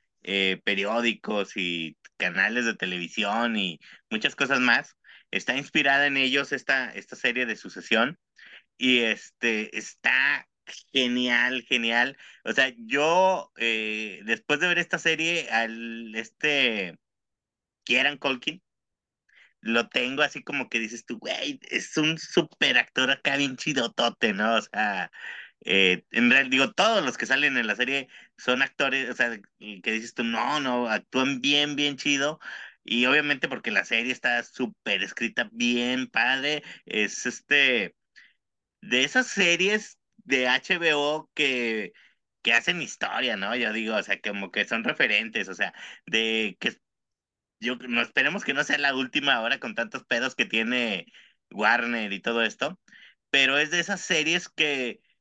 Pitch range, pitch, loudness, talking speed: 115-145 Hz, 125 Hz, -25 LUFS, 150 wpm